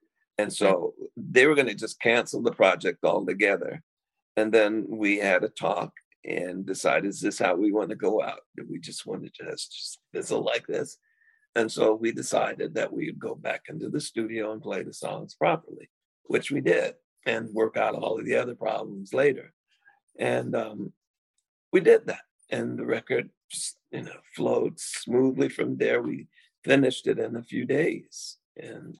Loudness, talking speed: -27 LUFS, 180 wpm